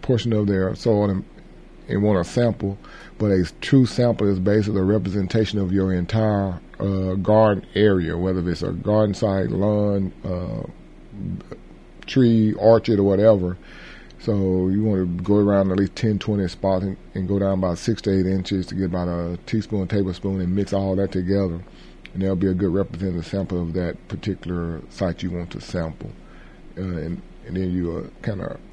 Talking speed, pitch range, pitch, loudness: 180 wpm, 90-105 Hz, 95 Hz, -22 LUFS